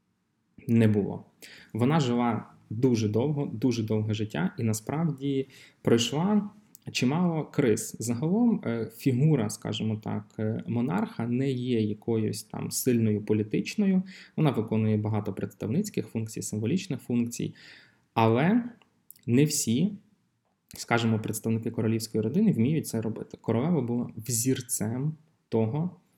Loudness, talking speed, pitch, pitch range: -28 LUFS, 105 wpm, 120 Hz, 110-150 Hz